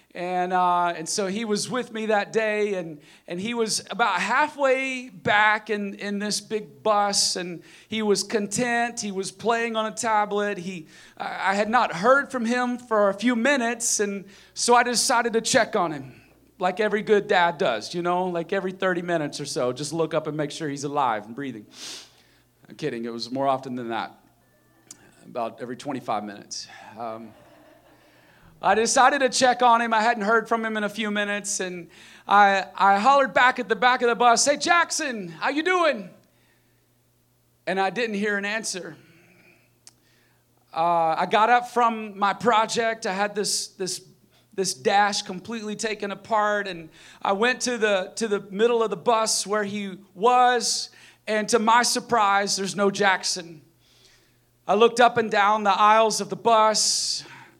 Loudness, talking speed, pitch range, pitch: -23 LUFS, 180 wpm, 180-230 Hz, 205 Hz